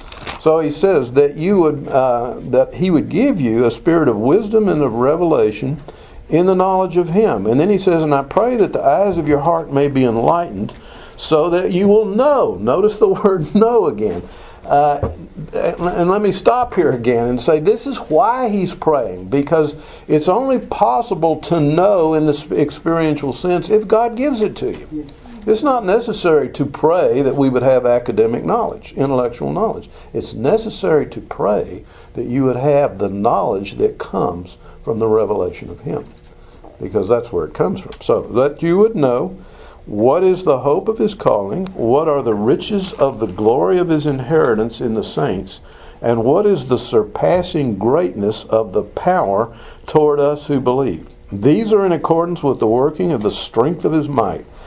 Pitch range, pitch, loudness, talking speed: 135-205 Hz, 160 Hz, -16 LUFS, 185 wpm